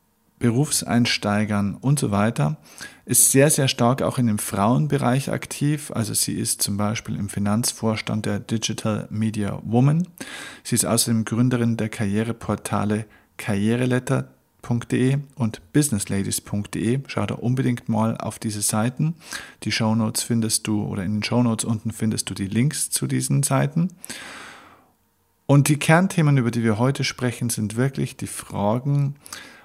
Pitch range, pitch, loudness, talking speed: 105-135 Hz, 115 Hz, -22 LUFS, 140 wpm